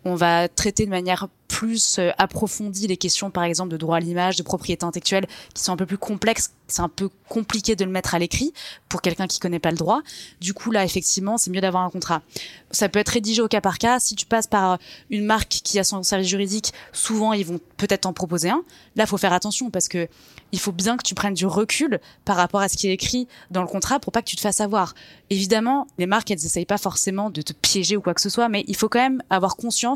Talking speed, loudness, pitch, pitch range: 260 wpm, -22 LUFS, 195 Hz, 180-220 Hz